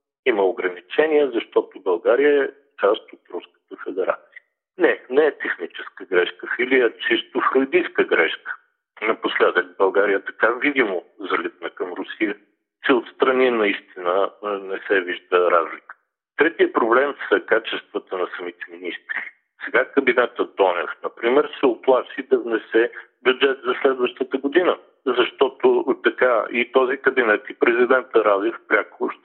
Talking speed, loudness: 125 wpm, -20 LUFS